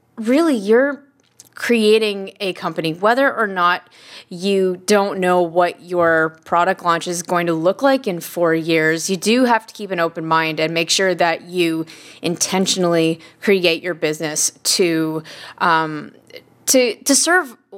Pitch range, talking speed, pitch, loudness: 165-210 Hz, 150 wpm, 180 Hz, -17 LUFS